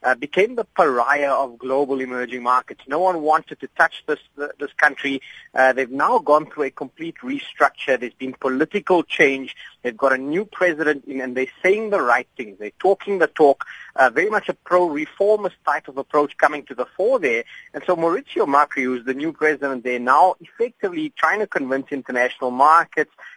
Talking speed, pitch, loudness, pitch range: 195 wpm, 150 Hz, -20 LUFS, 130-185 Hz